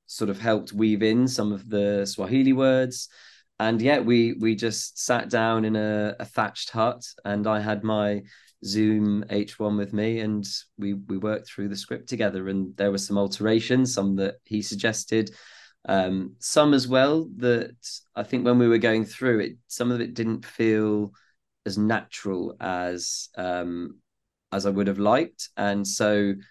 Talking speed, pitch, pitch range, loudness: 170 wpm, 105 Hz, 100-115 Hz, -25 LUFS